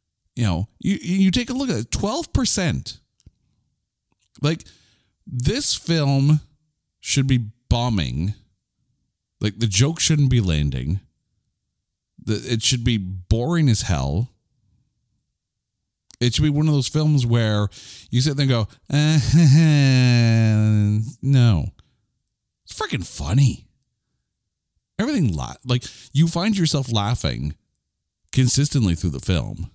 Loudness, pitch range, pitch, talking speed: -20 LUFS, 105-140 Hz, 120 Hz, 115 wpm